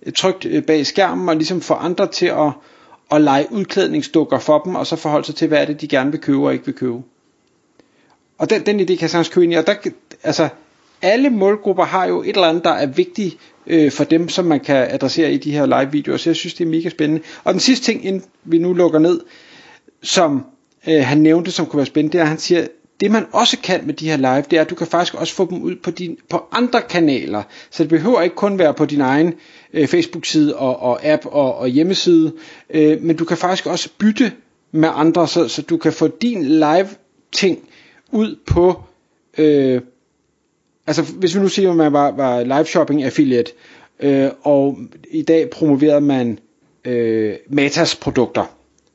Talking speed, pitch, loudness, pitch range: 210 wpm, 165 Hz, -16 LUFS, 150-185 Hz